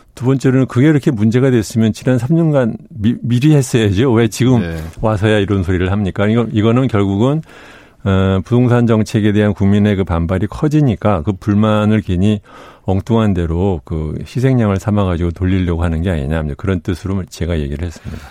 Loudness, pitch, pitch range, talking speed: -15 LUFS, 105 Hz, 95-120 Hz, 375 characters per minute